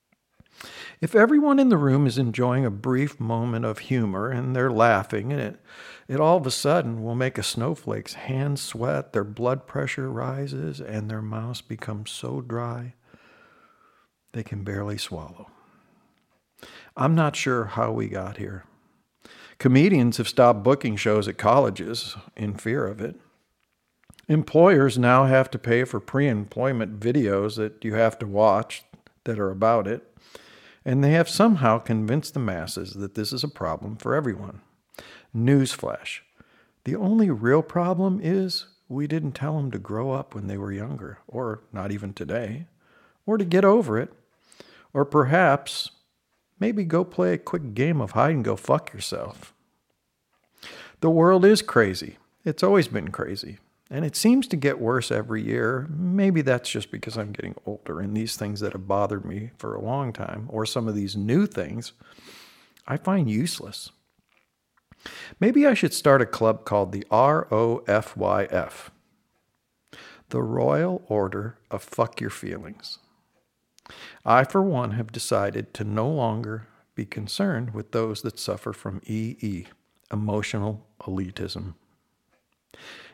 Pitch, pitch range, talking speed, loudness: 115 Hz, 105-140 Hz, 155 wpm, -24 LUFS